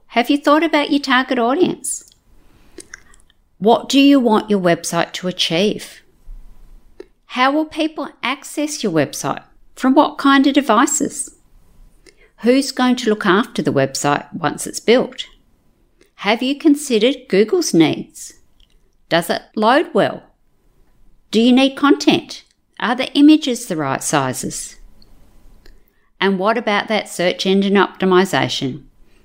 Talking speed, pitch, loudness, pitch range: 125 wpm, 240 Hz, -16 LUFS, 195-285 Hz